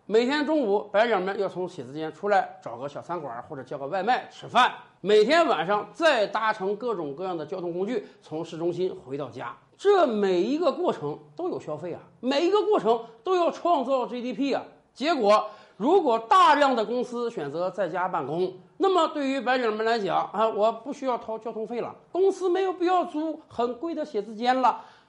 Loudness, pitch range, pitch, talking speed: -25 LUFS, 180-280 Hz, 220 Hz, 290 characters per minute